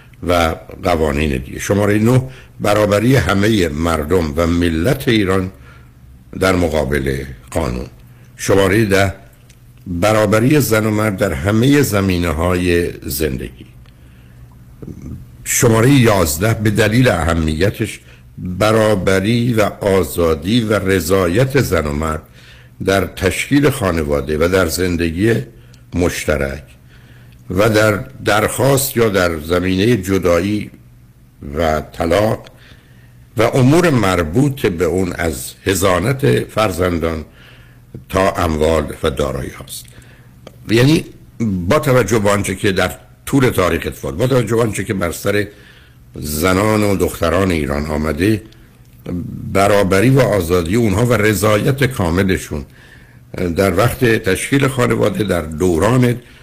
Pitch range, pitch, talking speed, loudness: 80-115 Hz, 95 Hz, 105 wpm, -15 LUFS